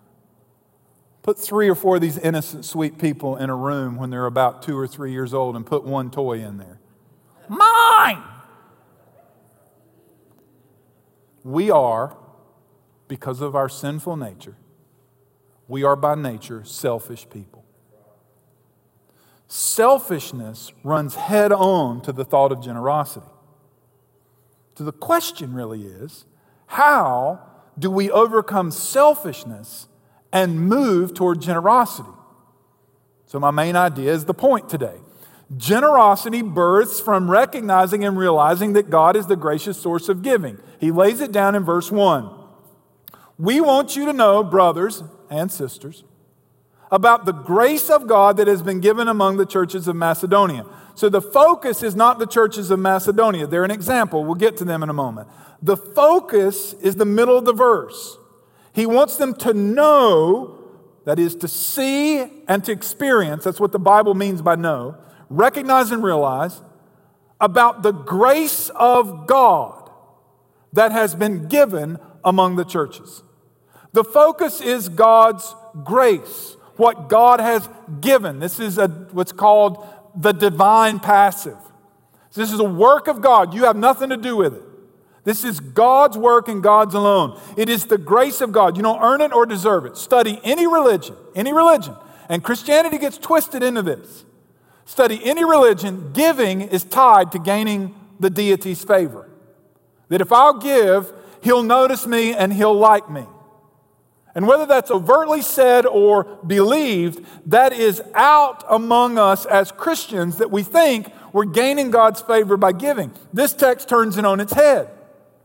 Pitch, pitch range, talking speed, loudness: 200 Hz, 155-235 Hz, 150 wpm, -17 LUFS